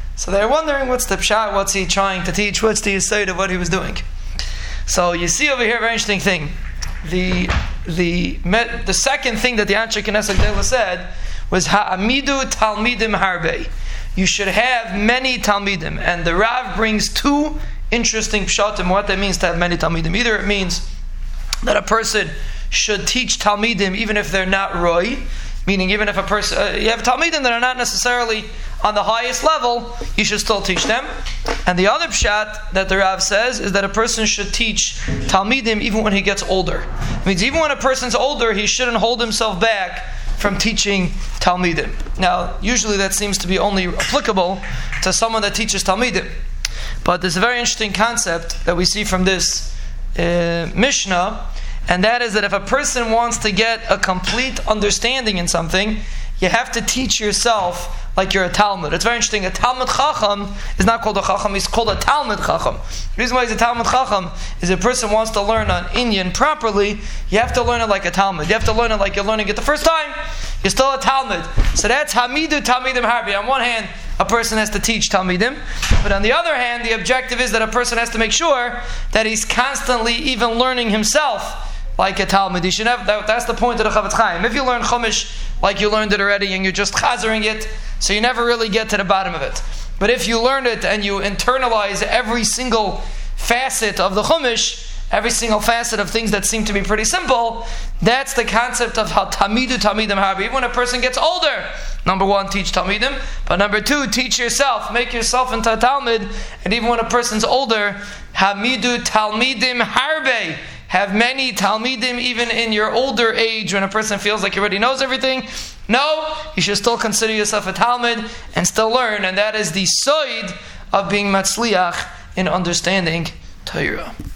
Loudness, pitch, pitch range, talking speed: -17 LUFS, 215 Hz, 195-240 Hz, 200 wpm